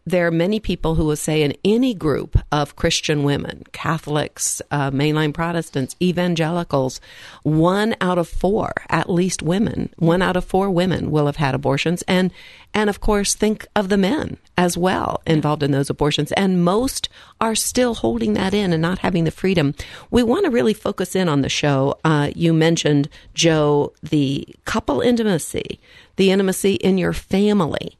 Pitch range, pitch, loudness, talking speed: 150-190 Hz, 170 Hz, -19 LUFS, 175 wpm